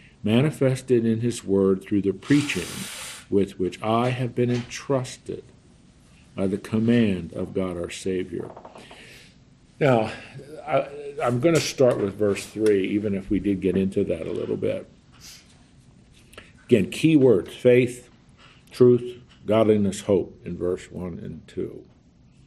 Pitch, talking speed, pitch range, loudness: 110 Hz, 135 wpm, 95-125 Hz, -23 LUFS